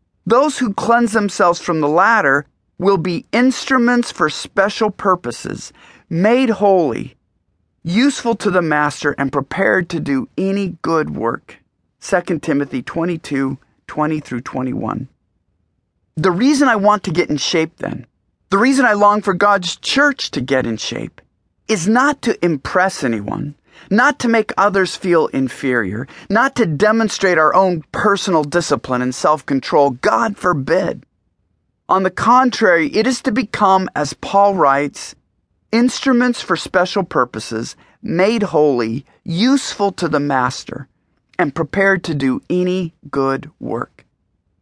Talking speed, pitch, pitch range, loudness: 135 wpm, 180 Hz, 140-210 Hz, -16 LUFS